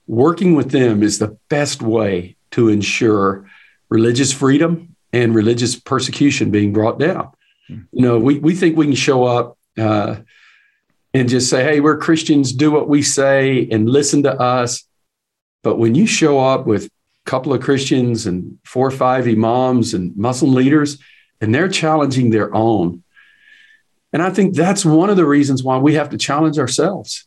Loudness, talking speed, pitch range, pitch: -15 LUFS, 170 wpm, 115-150 Hz, 130 Hz